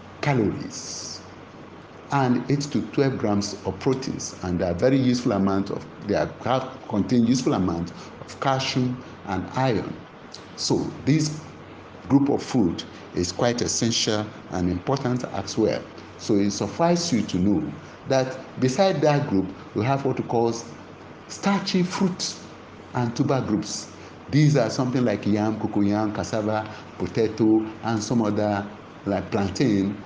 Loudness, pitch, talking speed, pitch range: -24 LUFS, 110 Hz, 135 wpm, 100-130 Hz